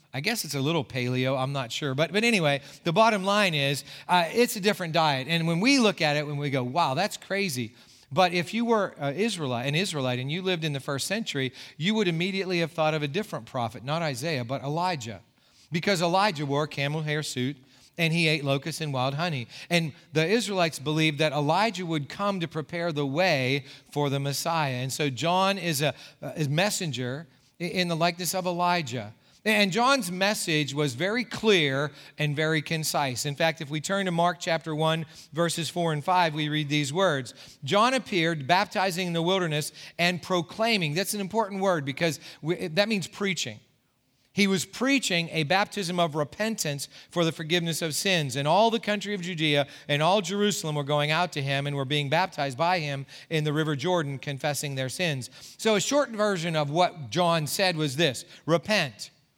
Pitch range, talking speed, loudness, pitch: 145-185 Hz, 195 wpm, -26 LUFS, 160 Hz